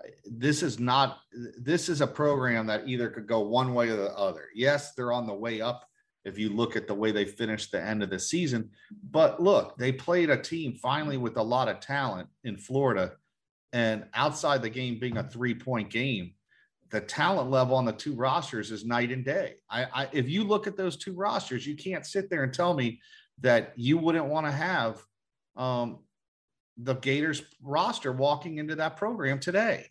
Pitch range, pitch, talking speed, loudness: 115-155 Hz, 130 Hz, 200 wpm, -29 LUFS